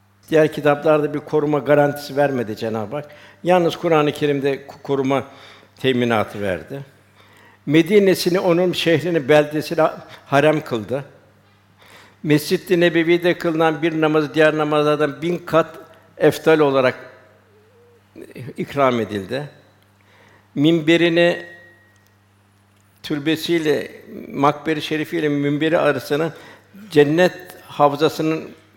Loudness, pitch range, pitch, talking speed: -18 LUFS, 110-160 Hz, 145 Hz, 90 wpm